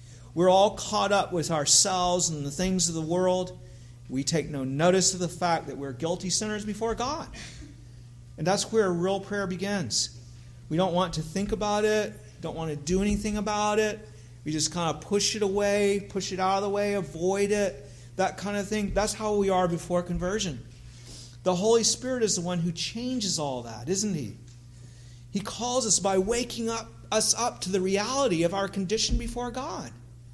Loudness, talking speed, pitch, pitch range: -27 LUFS, 195 wpm, 185 Hz, 145-205 Hz